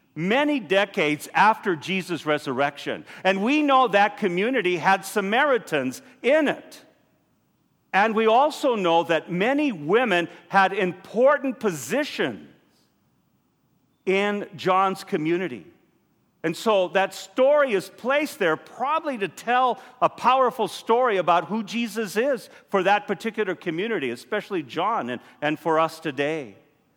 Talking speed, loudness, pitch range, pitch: 120 wpm, -23 LUFS, 175-250 Hz, 200 Hz